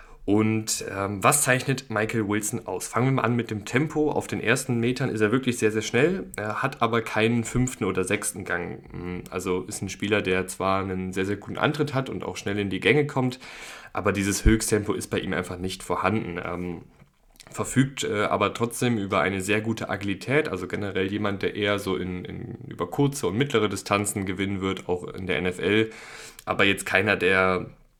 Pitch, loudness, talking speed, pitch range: 105 Hz, -25 LUFS, 200 wpm, 95-115 Hz